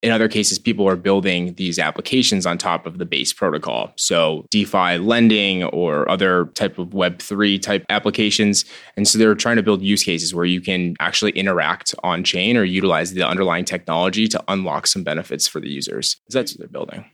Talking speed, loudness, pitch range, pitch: 195 wpm, -18 LUFS, 90-105 Hz, 100 Hz